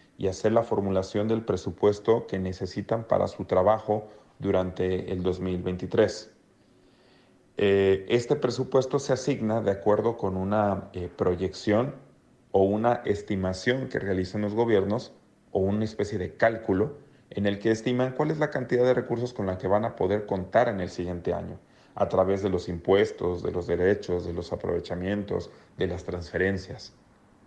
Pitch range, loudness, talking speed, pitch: 95-120 Hz, -27 LUFS, 155 wpm, 105 Hz